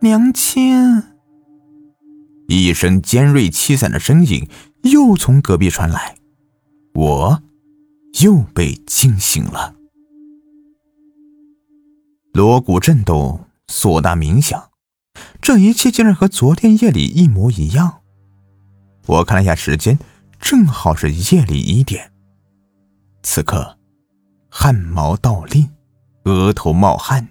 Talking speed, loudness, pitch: 150 characters per minute, -13 LUFS, 140 Hz